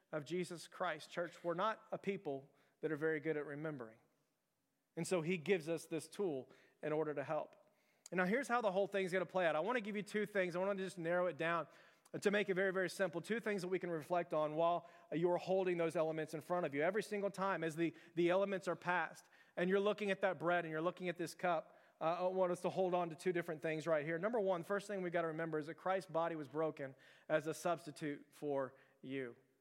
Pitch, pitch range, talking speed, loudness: 170 Hz, 155-190 Hz, 250 wpm, -40 LUFS